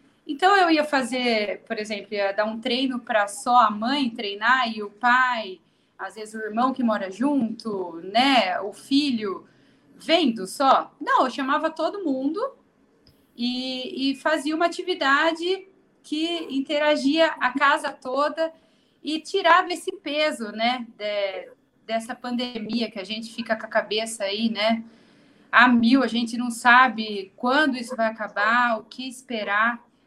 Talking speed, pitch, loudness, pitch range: 150 wpm, 250 Hz, -23 LUFS, 225-300 Hz